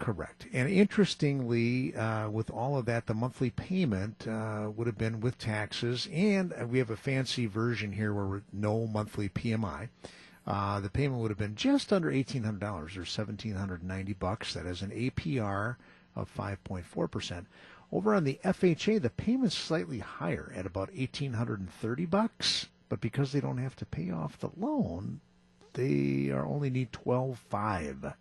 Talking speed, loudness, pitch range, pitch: 175 wpm, -32 LUFS, 100-135 Hz, 115 Hz